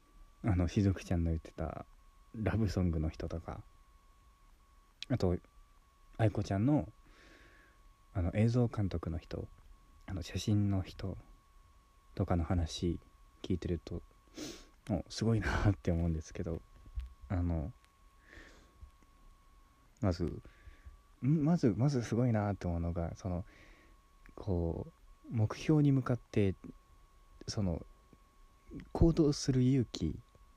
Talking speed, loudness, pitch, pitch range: 200 characters per minute, -35 LUFS, 90 Hz, 85-110 Hz